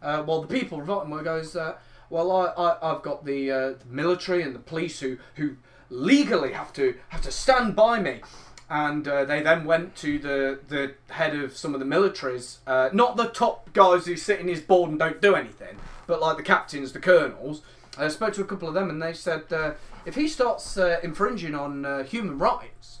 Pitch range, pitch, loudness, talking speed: 140-185 Hz, 160 Hz, -25 LUFS, 220 wpm